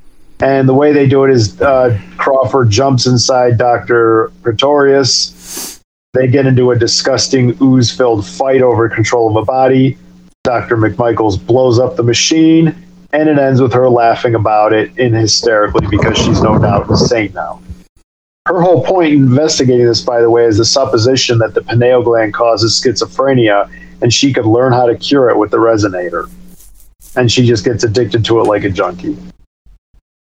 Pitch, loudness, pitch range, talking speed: 120 Hz, -10 LUFS, 110-130 Hz, 170 wpm